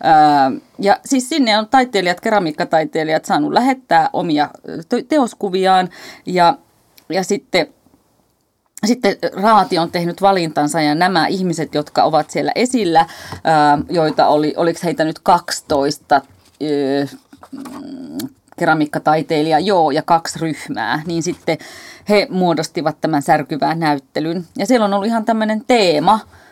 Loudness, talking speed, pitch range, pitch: -16 LUFS, 115 wpm, 155-220 Hz, 175 Hz